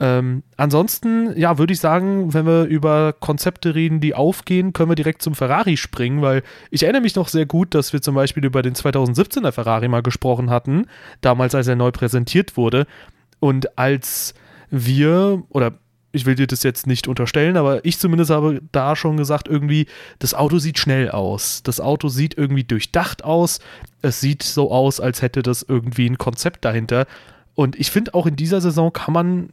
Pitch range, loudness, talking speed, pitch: 130-165 Hz, -18 LUFS, 190 wpm, 145 Hz